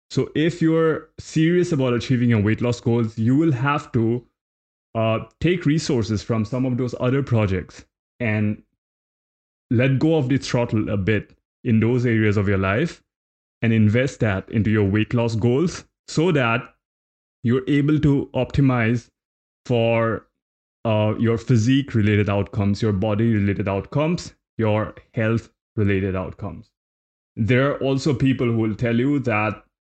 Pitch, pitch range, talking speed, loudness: 115 Hz, 105-130 Hz, 150 wpm, -21 LUFS